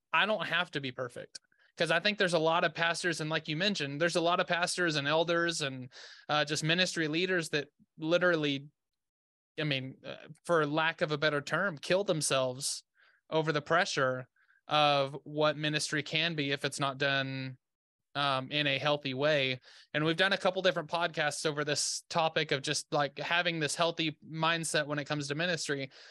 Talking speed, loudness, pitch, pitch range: 190 wpm, -31 LUFS, 155 Hz, 145-170 Hz